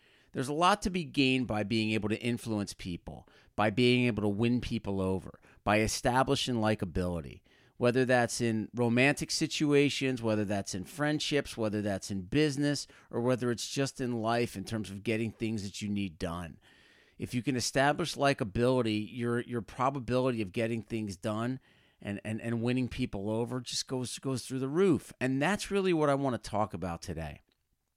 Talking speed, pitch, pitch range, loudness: 180 wpm, 120 Hz, 105-135 Hz, -31 LUFS